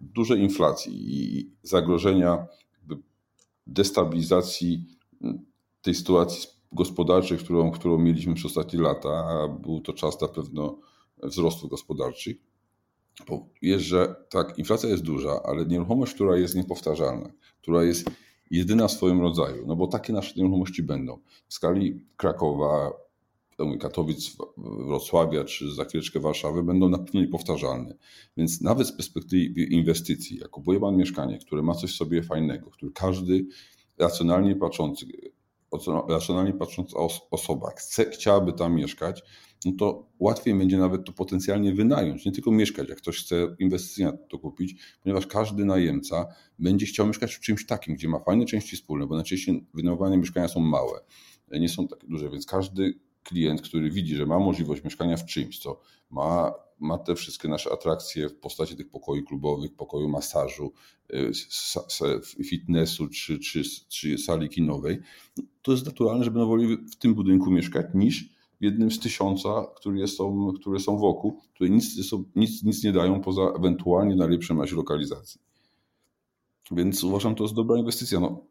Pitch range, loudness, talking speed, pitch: 85-95 Hz, -26 LUFS, 150 wpm, 90 Hz